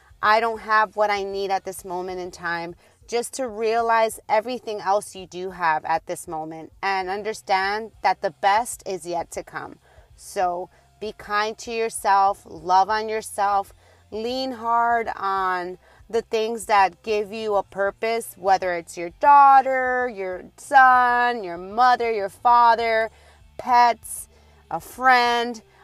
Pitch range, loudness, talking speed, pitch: 190-230 Hz, -21 LUFS, 145 wpm, 210 Hz